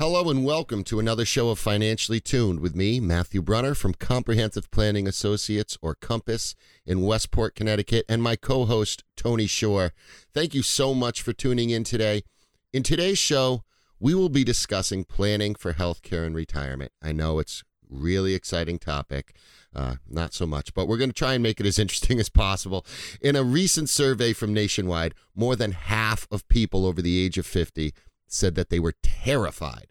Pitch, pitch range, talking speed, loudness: 105 Hz, 90-120 Hz, 185 wpm, -25 LUFS